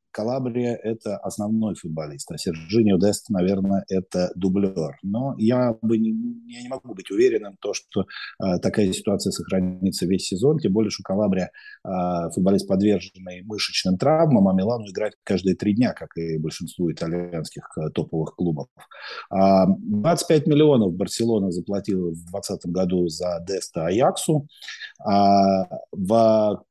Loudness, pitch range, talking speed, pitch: -23 LUFS, 90-115 Hz, 140 wpm, 100 Hz